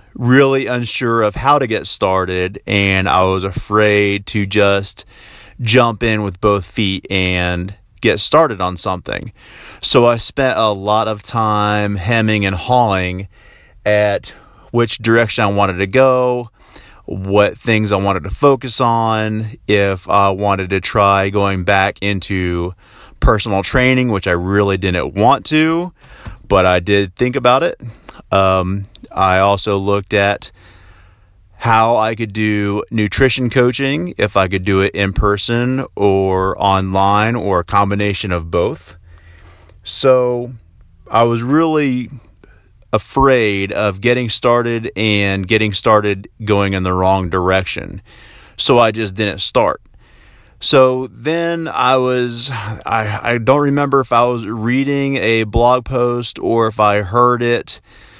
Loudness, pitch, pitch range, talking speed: -15 LUFS, 105 Hz, 95-120 Hz, 140 wpm